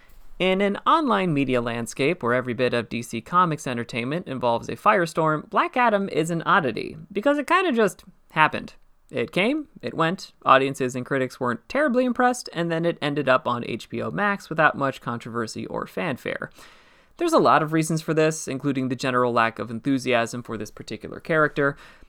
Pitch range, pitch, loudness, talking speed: 120-180 Hz, 145 Hz, -23 LUFS, 180 wpm